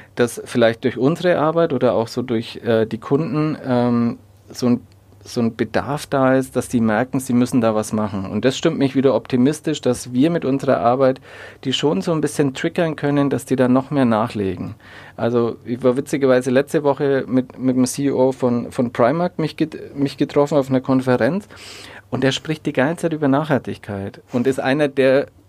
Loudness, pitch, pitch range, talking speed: -19 LUFS, 130 Hz, 115-140 Hz, 200 wpm